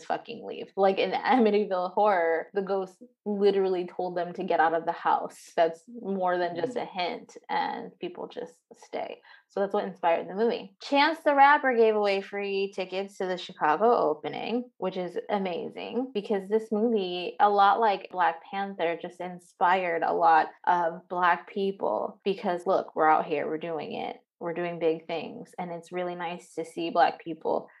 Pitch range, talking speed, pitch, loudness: 175-225 Hz, 175 wpm, 195 Hz, -27 LUFS